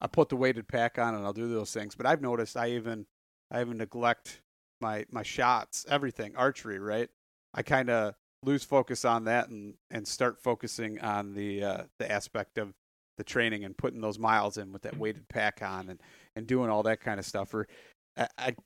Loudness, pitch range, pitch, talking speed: -32 LUFS, 105-120 Hz, 110 Hz, 210 wpm